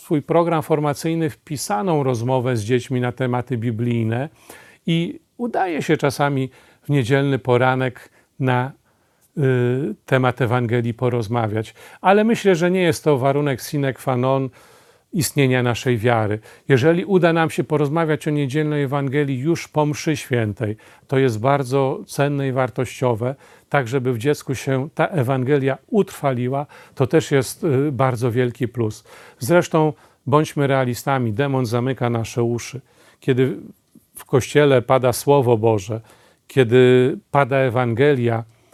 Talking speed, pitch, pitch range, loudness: 130 wpm, 135 Hz, 125-150 Hz, -20 LUFS